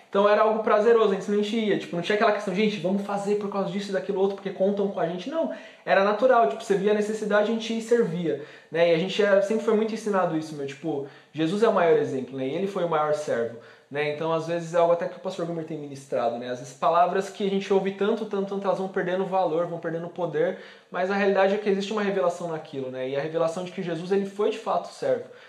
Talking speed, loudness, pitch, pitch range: 270 wpm, -25 LUFS, 195 Hz, 170-210 Hz